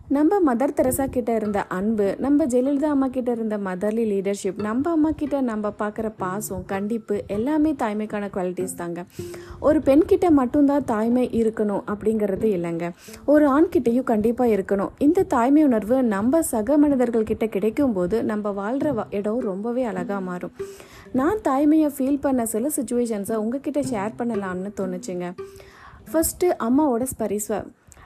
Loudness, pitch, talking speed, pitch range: -22 LUFS, 230 Hz, 135 wpm, 205-285 Hz